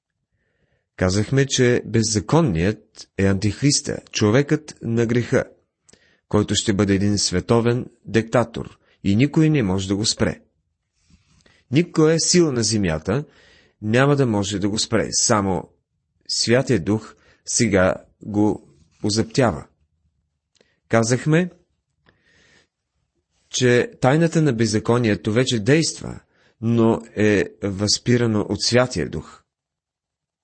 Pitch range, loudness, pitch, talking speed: 100-125 Hz, -20 LUFS, 110 Hz, 100 wpm